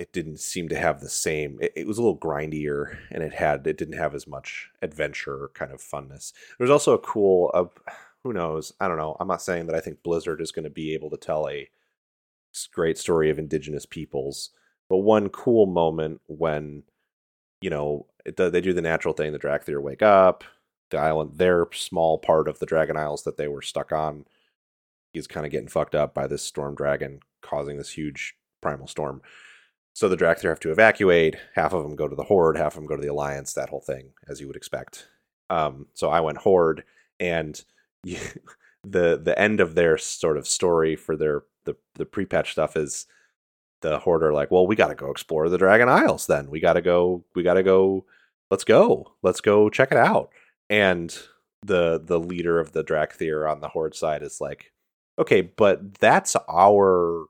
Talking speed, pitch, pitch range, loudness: 200 wpm, 80 Hz, 75-85 Hz, -23 LUFS